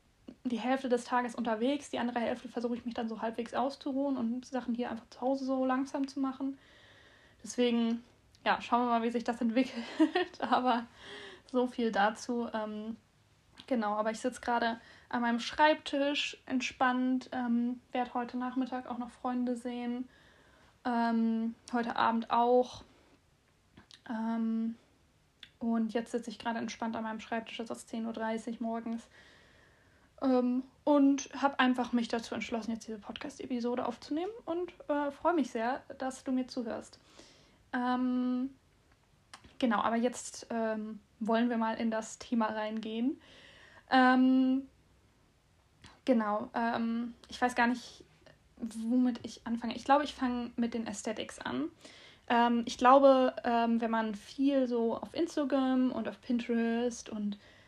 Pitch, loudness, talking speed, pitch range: 245 Hz, -33 LUFS, 145 wpm, 230-260 Hz